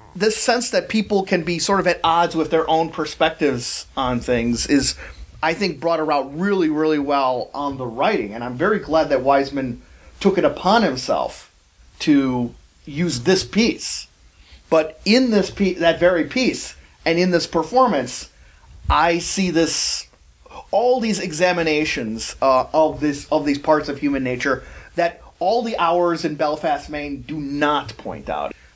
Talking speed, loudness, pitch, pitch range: 165 wpm, -20 LUFS, 155 Hz, 135-175 Hz